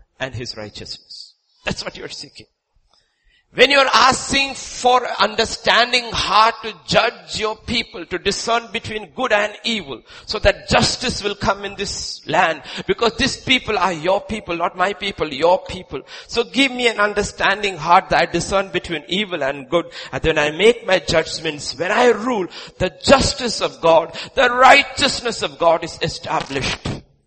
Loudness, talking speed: -17 LUFS, 165 wpm